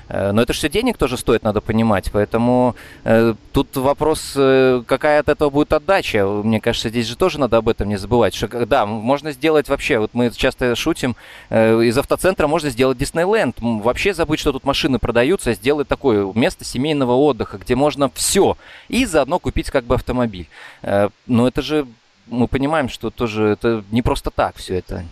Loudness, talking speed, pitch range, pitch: -18 LUFS, 185 wpm, 115-145 Hz, 125 Hz